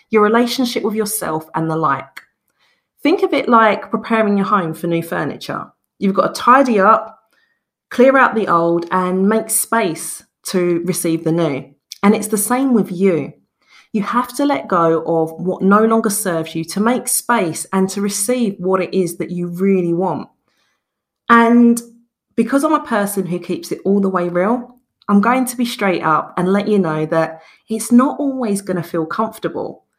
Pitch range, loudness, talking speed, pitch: 175-235 Hz, -16 LUFS, 185 wpm, 205 Hz